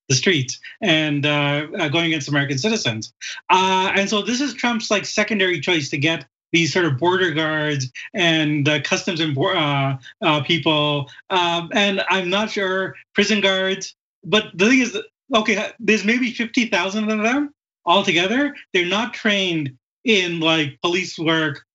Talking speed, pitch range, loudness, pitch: 140 wpm, 155-210 Hz, -19 LUFS, 180 Hz